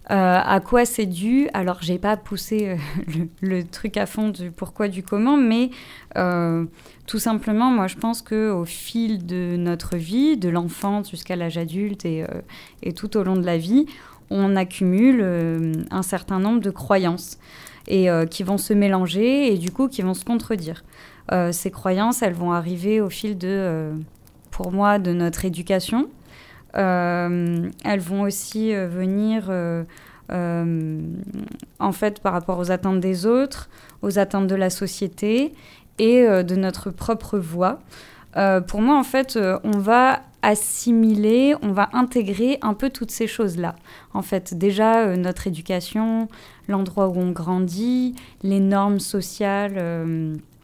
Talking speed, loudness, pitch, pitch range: 165 wpm, -22 LUFS, 195 Hz, 180-220 Hz